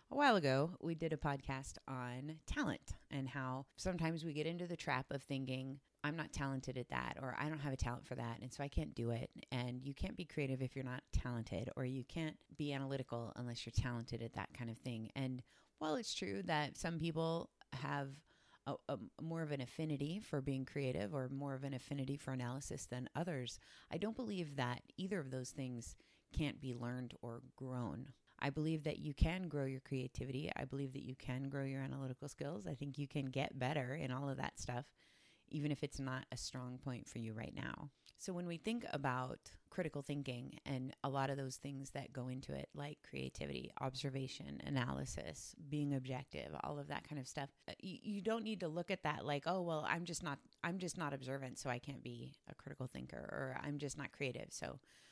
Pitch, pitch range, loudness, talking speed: 135 Hz, 125-150 Hz, -44 LUFS, 215 wpm